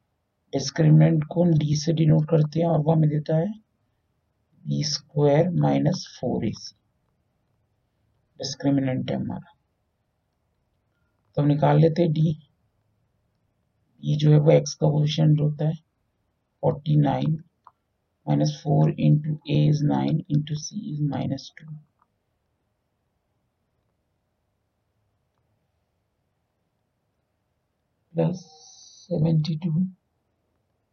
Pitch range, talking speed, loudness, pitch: 105-155 Hz, 40 wpm, -23 LUFS, 145 Hz